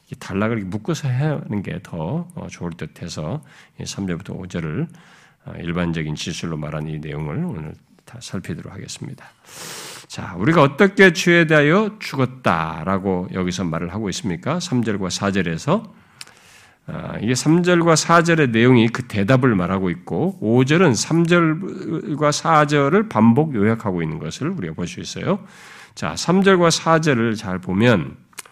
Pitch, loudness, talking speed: 130 Hz, -19 LUFS, 270 characters per minute